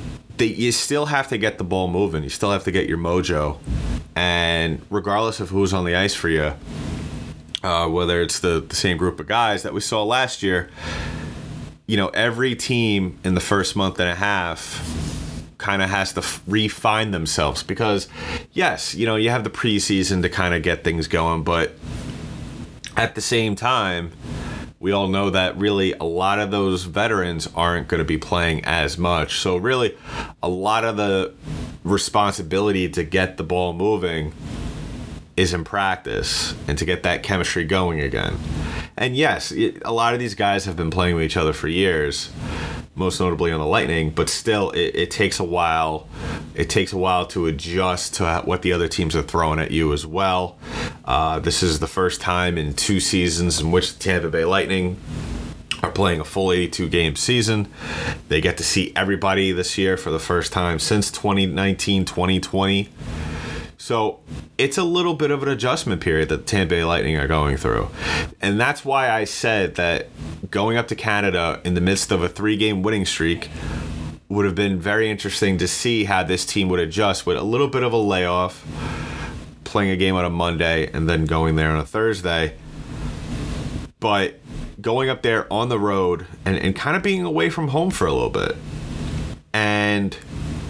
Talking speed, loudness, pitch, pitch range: 185 wpm, -21 LUFS, 90 Hz, 80-100 Hz